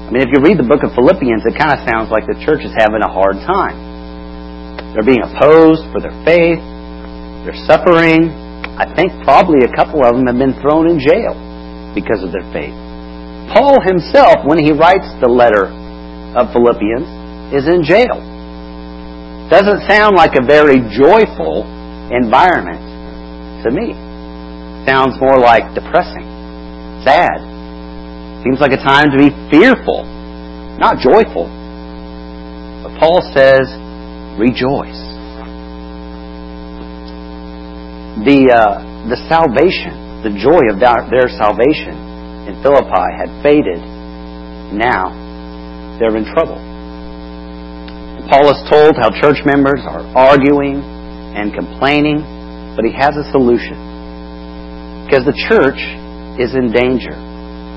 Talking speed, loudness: 125 wpm, -11 LUFS